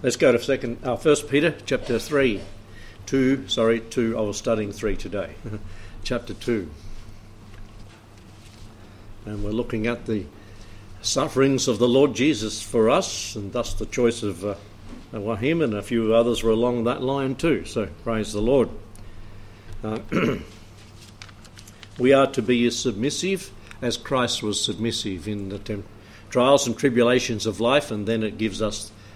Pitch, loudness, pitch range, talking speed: 110 Hz, -23 LUFS, 105-120 Hz, 150 wpm